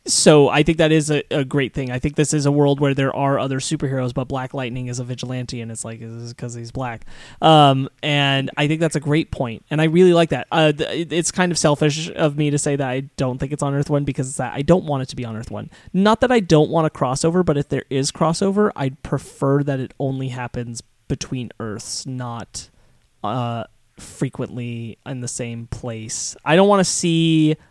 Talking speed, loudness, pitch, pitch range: 235 wpm, -19 LUFS, 140 Hz, 125-155 Hz